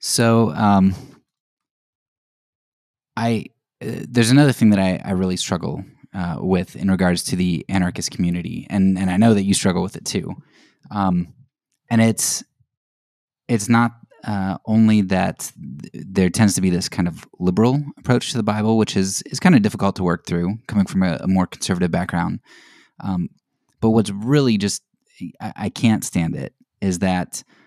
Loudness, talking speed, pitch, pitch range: -19 LUFS, 170 wpm, 100 Hz, 90-115 Hz